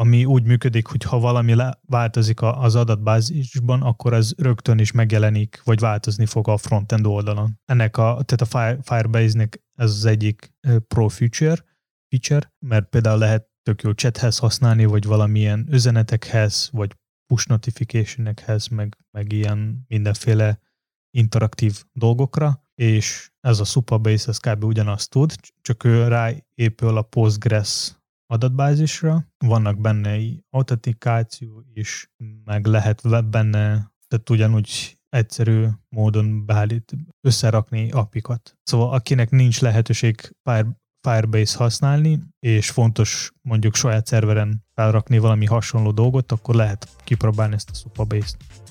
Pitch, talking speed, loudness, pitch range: 115 Hz, 130 wpm, -20 LUFS, 110-125 Hz